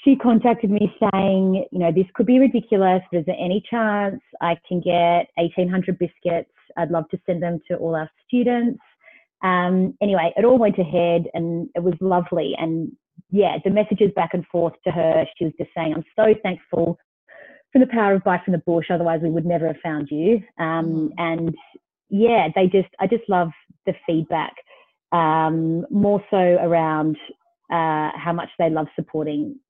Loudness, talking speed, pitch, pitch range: -21 LUFS, 180 wpm, 180 Hz, 165-205 Hz